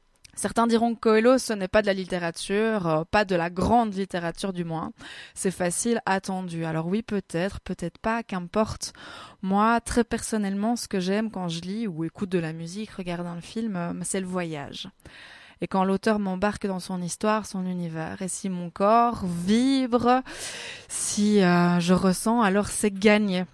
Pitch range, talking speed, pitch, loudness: 180-220 Hz, 170 wpm, 195 Hz, -25 LUFS